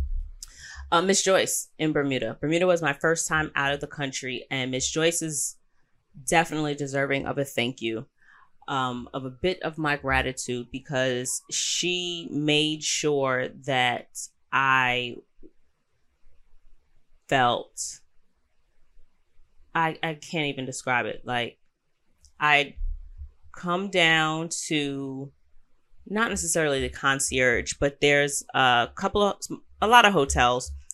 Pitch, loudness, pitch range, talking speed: 140 Hz, -25 LUFS, 120-160 Hz, 120 wpm